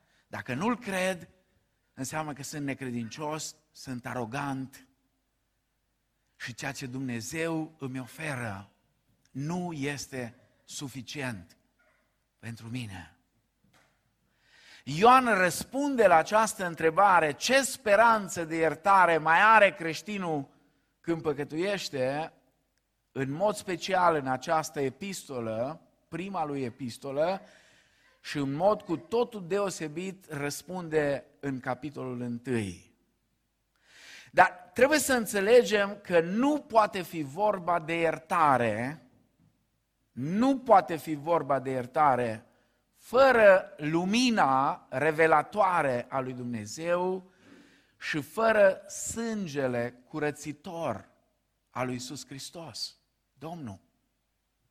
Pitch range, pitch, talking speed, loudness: 130-185 Hz, 155 Hz, 95 wpm, -28 LUFS